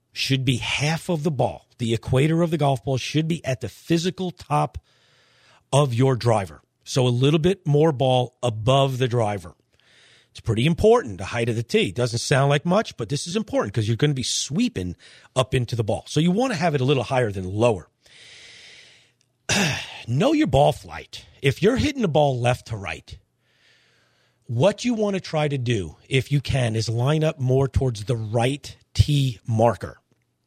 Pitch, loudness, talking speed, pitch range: 130 Hz, -22 LUFS, 195 wpm, 115-155 Hz